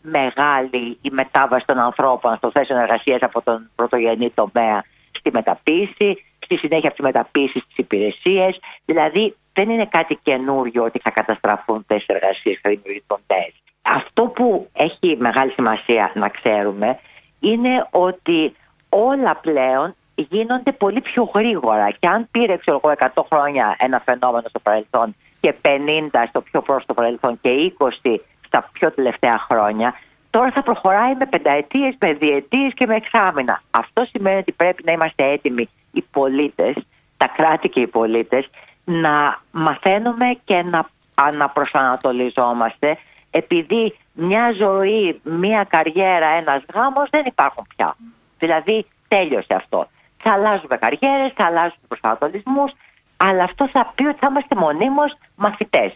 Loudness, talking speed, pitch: -18 LUFS, 135 wpm, 155 Hz